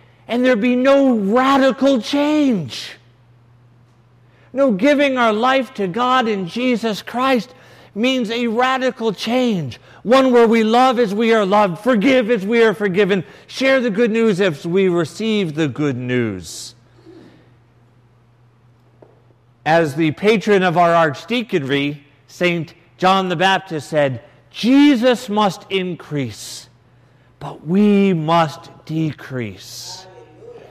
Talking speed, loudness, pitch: 115 wpm, -16 LUFS, 190 Hz